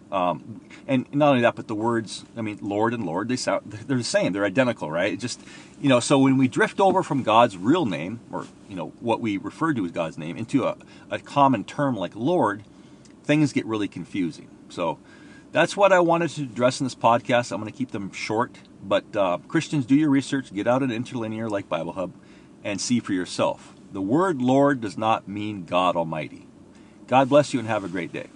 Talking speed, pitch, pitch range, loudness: 220 wpm, 125 Hz, 115-145 Hz, -23 LUFS